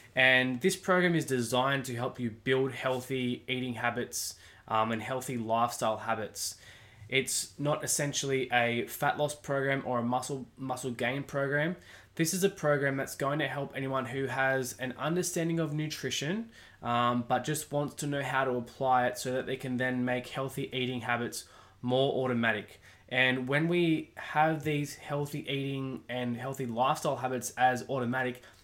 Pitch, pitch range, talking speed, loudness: 130 Hz, 120-140 Hz, 165 wpm, -31 LUFS